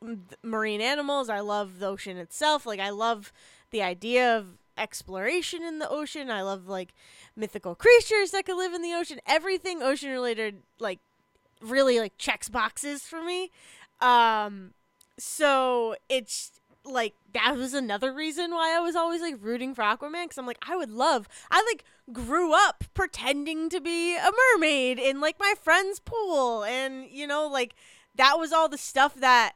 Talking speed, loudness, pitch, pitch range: 170 wpm, -26 LUFS, 270 Hz, 225-330 Hz